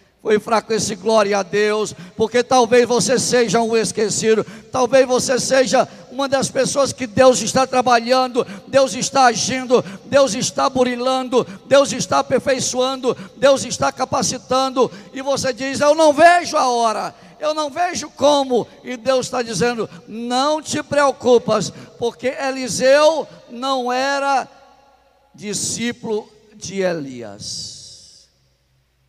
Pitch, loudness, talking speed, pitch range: 250 Hz, -17 LUFS, 125 wpm, 220-265 Hz